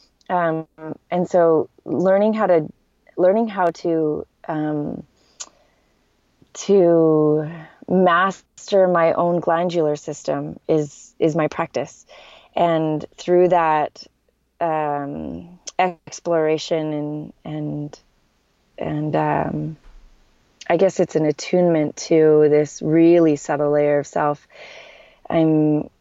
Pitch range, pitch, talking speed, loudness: 150-175 Hz, 160 Hz, 95 wpm, -19 LUFS